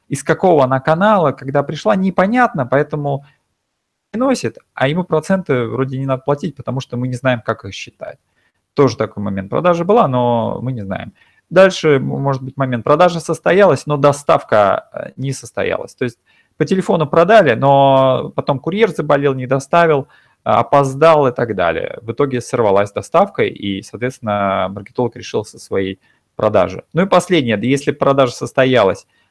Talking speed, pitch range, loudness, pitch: 155 wpm, 125-165 Hz, -15 LUFS, 140 Hz